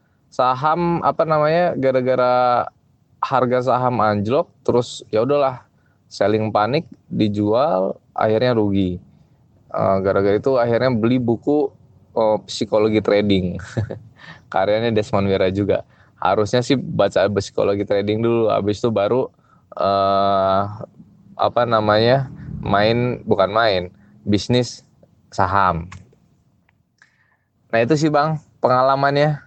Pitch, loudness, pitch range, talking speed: 115 Hz, -19 LUFS, 100-130 Hz, 100 wpm